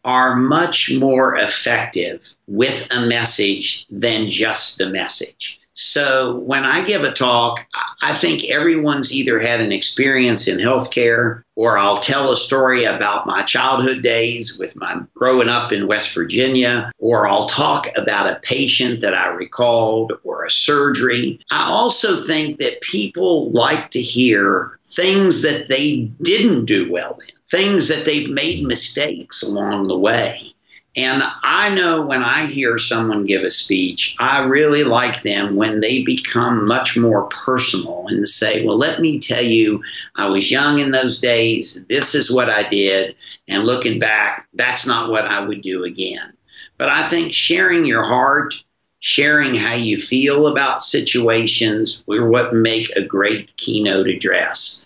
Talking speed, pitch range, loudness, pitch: 160 wpm, 110-135 Hz, -16 LUFS, 120 Hz